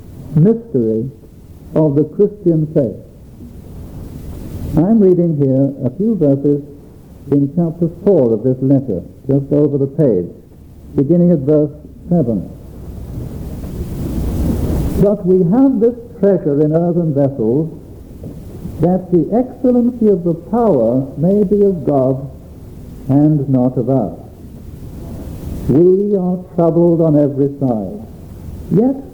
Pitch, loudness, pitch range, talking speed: 145 Hz, -14 LUFS, 110-175 Hz, 110 wpm